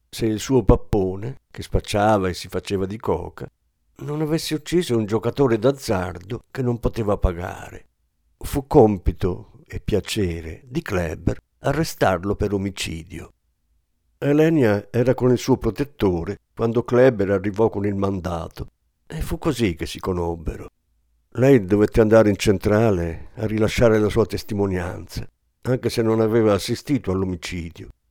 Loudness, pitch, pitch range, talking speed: -21 LUFS, 105 Hz, 95-120 Hz, 135 wpm